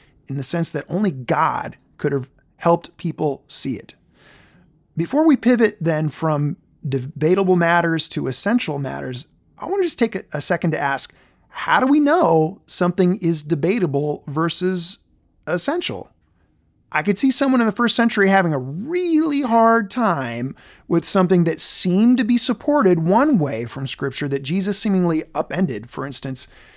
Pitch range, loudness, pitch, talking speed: 150-225 Hz, -19 LUFS, 175 Hz, 155 wpm